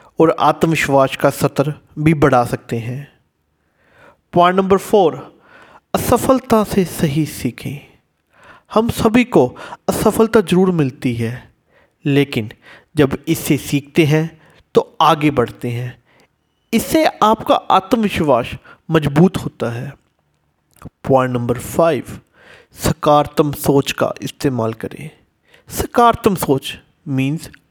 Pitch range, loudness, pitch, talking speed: 125-175 Hz, -16 LUFS, 145 Hz, 105 wpm